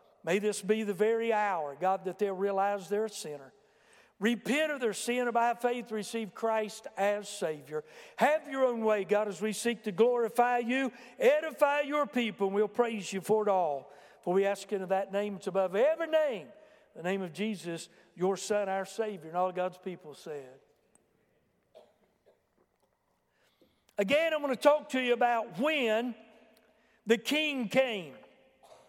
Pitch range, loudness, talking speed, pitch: 195-240 Hz, -31 LUFS, 165 wpm, 215 Hz